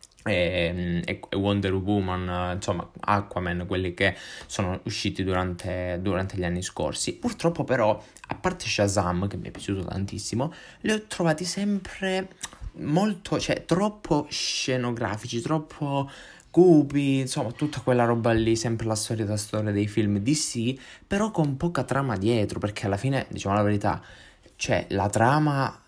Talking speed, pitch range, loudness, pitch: 145 wpm, 100-145 Hz, -26 LUFS, 110 Hz